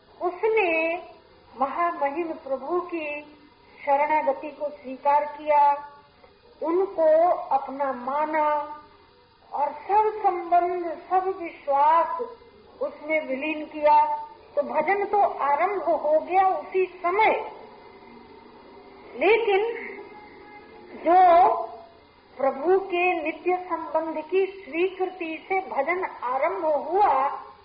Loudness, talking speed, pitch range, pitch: -24 LUFS, 90 wpm, 300-390 Hz, 345 Hz